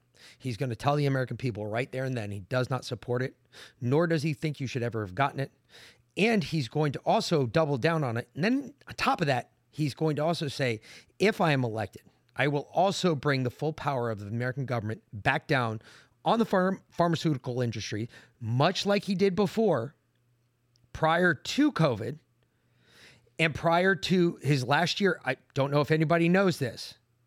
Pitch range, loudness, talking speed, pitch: 120-165 Hz, -28 LUFS, 195 wpm, 140 Hz